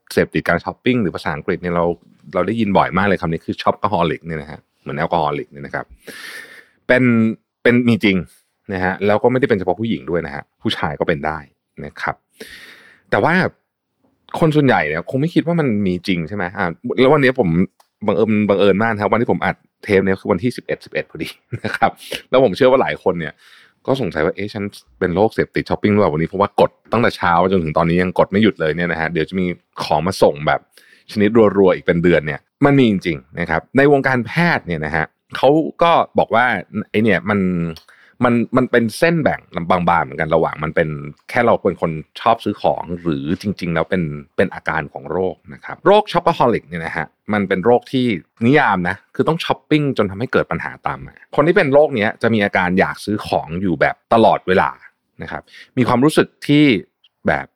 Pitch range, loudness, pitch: 85-120 Hz, -17 LUFS, 100 Hz